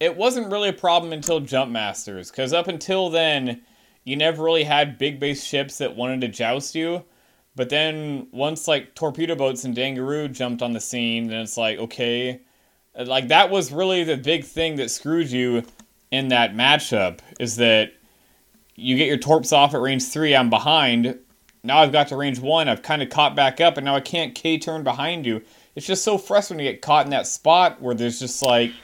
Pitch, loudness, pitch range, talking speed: 140 Hz, -21 LUFS, 125-160 Hz, 205 wpm